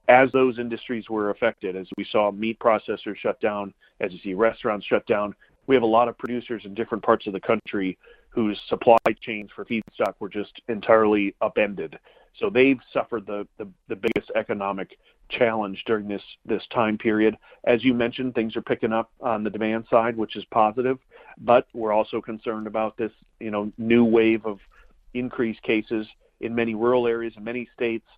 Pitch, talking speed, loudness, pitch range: 115 Hz, 185 wpm, -24 LUFS, 105-120 Hz